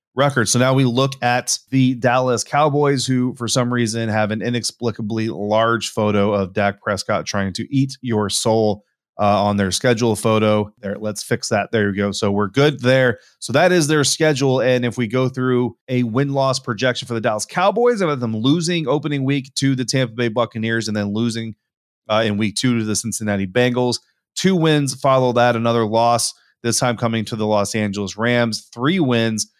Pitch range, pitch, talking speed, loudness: 110-130 Hz, 120 Hz, 200 wpm, -18 LUFS